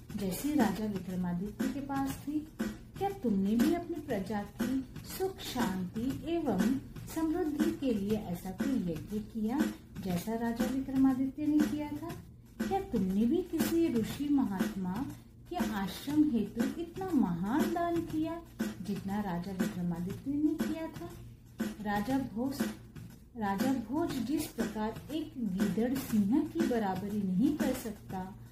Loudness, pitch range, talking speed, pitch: -34 LUFS, 200-285 Hz, 130 wpm, 235 Hz